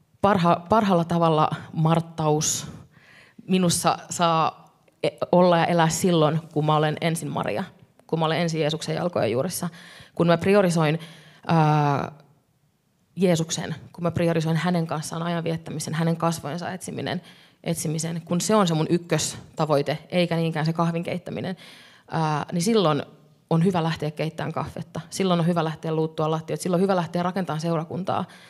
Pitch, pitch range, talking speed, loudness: 165 Hz, 155-175 Hz, 145 wpm, -24 LUFS